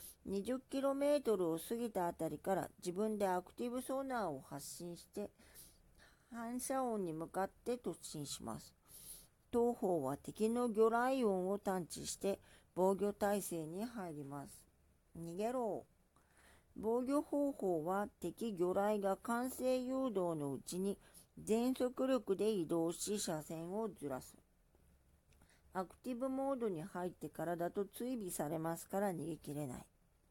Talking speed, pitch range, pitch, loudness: 250 characters per minute, 165-235 Hz, 195 Hz, -40 LUFS